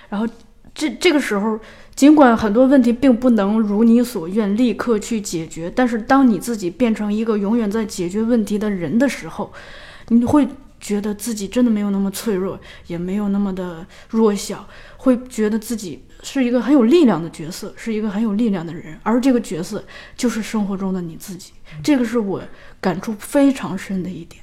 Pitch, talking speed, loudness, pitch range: 220 Hz, 290 characters per minute, -18 LUFS, 195-245 Hz